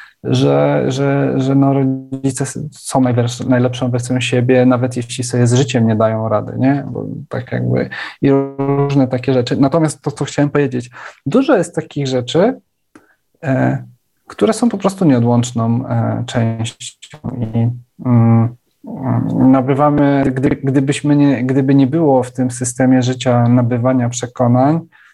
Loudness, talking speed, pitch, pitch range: -15 LUFS, 135 wpm, 130 Hz, 120-140 Hz